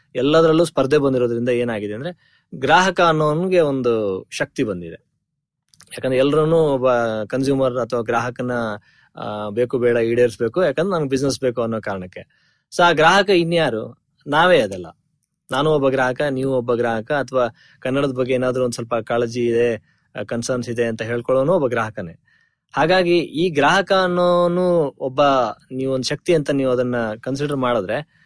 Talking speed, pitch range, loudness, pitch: 135 wpm, 120-155 Hz, -19 LUFS, 130 Hz